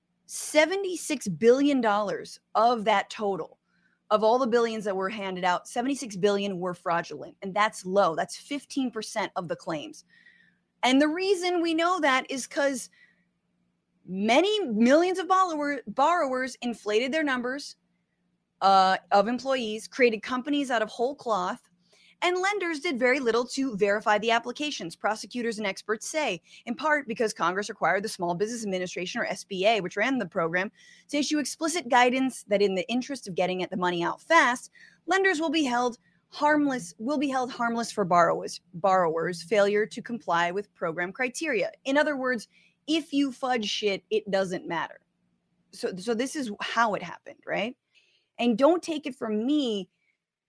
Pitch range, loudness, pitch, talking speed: 195-280 Hz, -26 LUFS, 230 Hz, 160 wpm